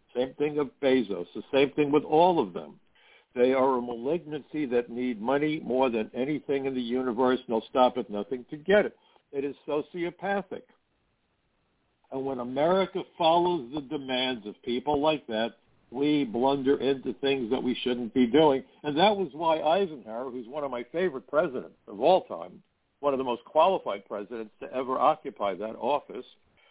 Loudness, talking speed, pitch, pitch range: -28 LUFS, 180 wpm, 135 Hz, 125-150 Hz